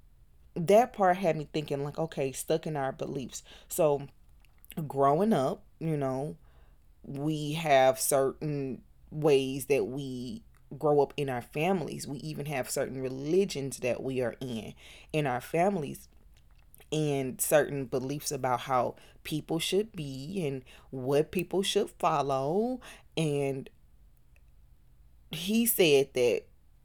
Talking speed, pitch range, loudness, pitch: 125 wpm, 125-160 Hz, -30 LUFS, 140 Hz